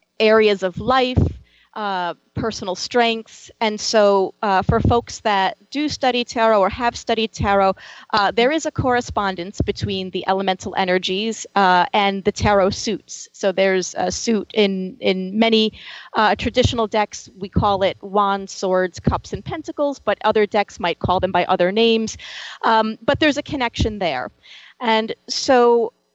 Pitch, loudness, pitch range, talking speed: 205 Hz, -19 LUFS, 190-230 Hz, 155 wpm